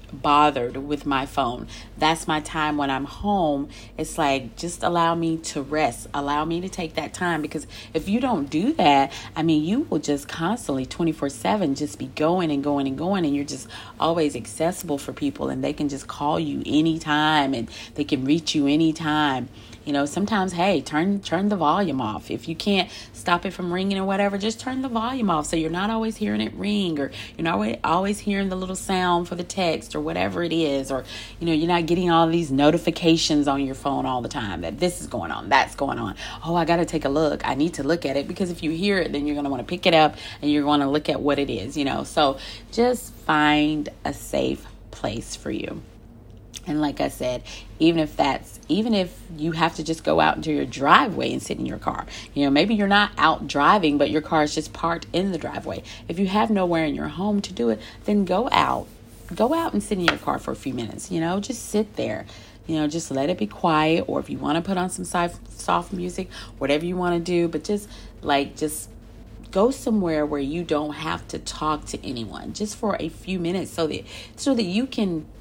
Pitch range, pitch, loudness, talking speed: 140-180 Hz, 155 Hz, -23 LUFS, 235 wpm